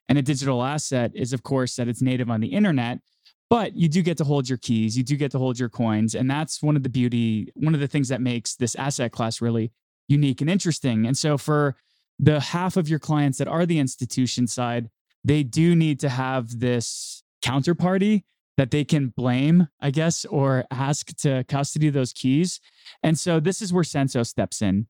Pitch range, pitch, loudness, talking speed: 125-155 Hz, 140 Hz, -23 LUFS, 210 wpm